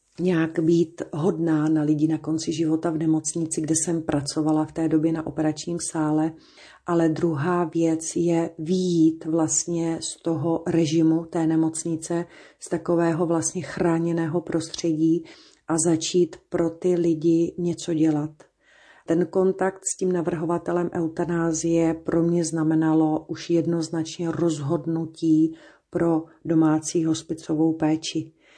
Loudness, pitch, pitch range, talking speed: -24 LUFS, 165 Hz, 160-170 Hz, 120 wpm